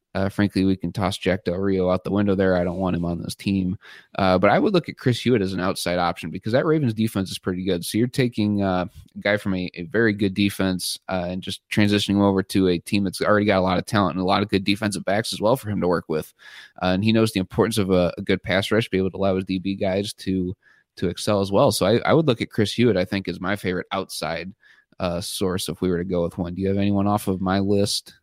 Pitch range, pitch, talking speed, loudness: 90-105 Hz, 95 Hz, 285 wpm, -22 LUFS